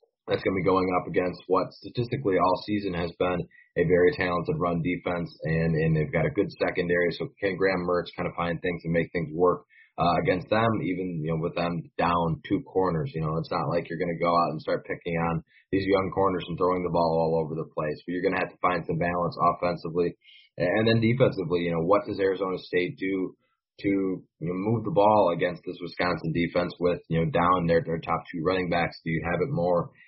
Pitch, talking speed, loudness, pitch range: 85 Hz, 235 wpm, -27 LUFS, 85-95 Hz